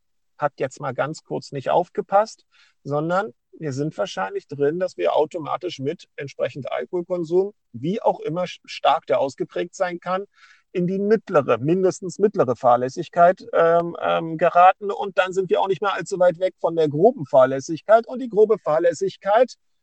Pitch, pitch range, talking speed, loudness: 180 Hz, 160-195 Hz, 160 wpm, -21 LUFS